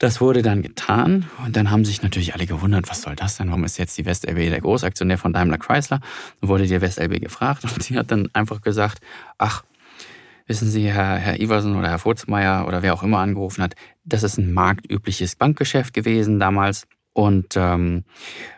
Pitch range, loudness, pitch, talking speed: 90-110 Hz, -21 LUFS, 100 Hz, 195 wpm